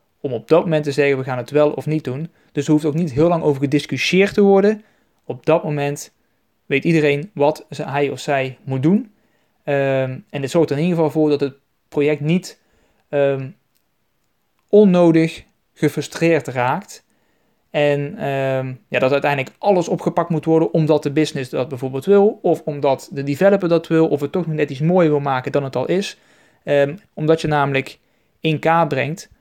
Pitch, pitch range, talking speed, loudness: 150 Hz, 140-165 Hz, 190 wpm, -18 LUFS